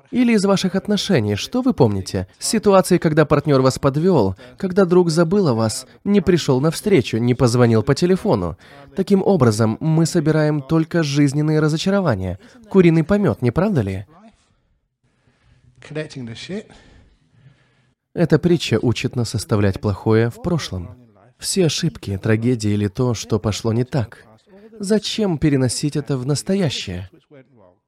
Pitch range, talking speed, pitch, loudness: 115-180 Hz, 125 wpm, 140 Hz, -18 LUFS